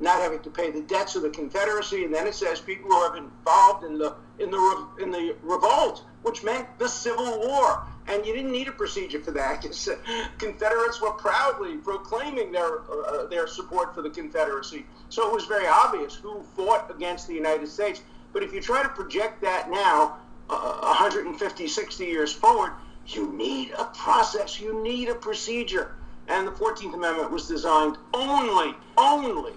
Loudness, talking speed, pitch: -25 LUFS, 180 wpm, 225 Hz